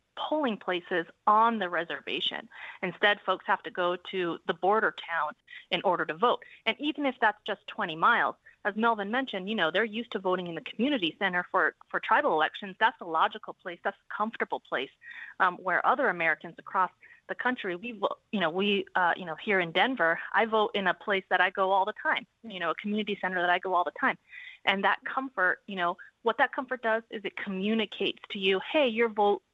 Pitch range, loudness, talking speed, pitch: 180-225 Hz, -29 LUFS, 215 wpm, 200 Hz